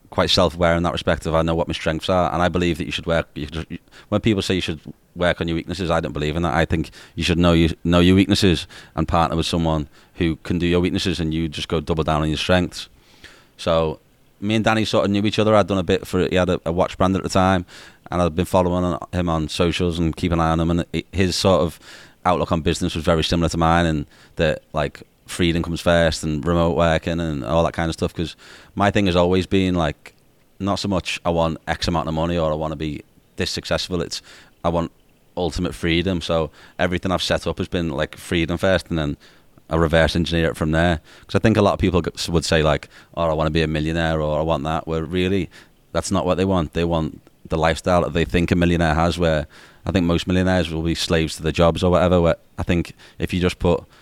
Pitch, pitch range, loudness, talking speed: 85 Hz, 80-90 Hz, -20 LUFS, 255 wpm